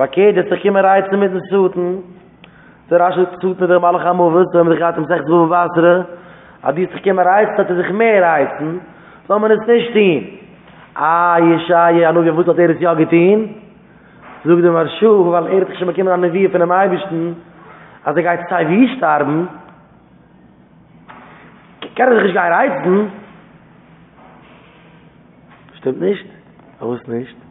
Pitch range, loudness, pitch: 170-190 Hz, -14 LUFS, 175 Hz